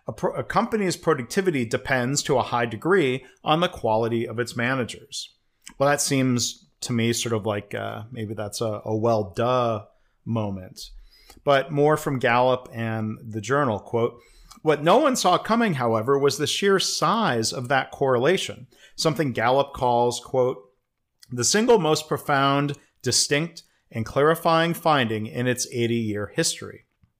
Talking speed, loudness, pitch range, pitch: 150 wpm, -23 LUFS, 115-150 Hz, 125 Hz